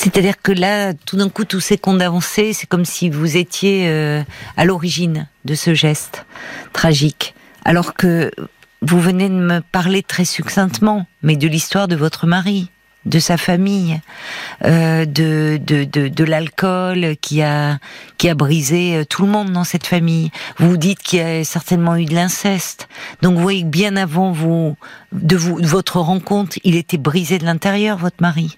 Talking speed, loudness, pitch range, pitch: 180 wpm, -16 LUFS, 160-190 Hz, 175 Hz